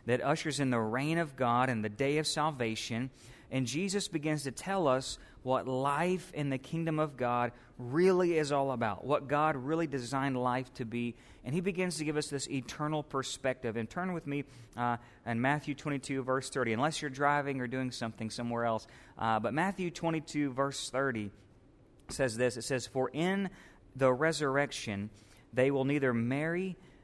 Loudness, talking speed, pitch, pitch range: -33 LUFS, 180 wpm, 135 Hz, 120-150 Hz